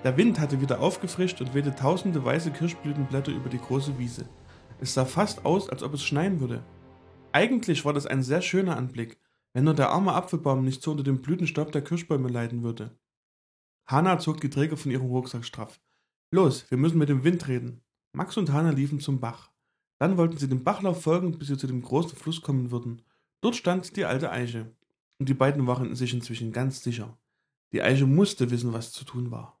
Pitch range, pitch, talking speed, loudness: 125-165 Hz, 140 Hz, 205 wpm, -27 LUFS